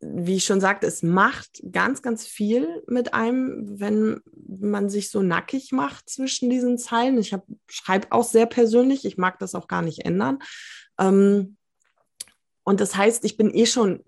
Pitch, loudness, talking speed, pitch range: 220 Hz, -22 LUFS, 165 wpm, 200-245 Hz